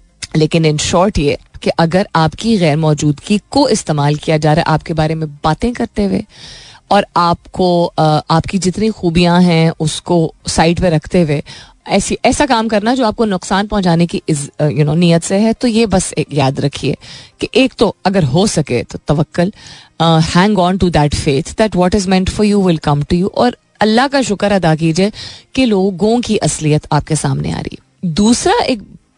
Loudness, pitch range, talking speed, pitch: -13 LUFS, 155-205 Hz, 190 wpm, 175 Hz